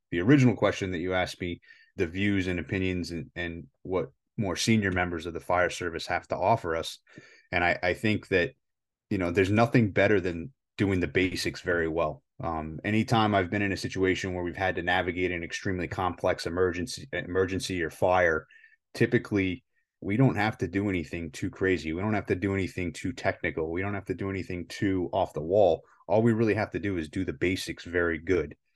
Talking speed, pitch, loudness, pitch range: 205 wpm, 95 Hz, -28 LUFS, 90-105 Hz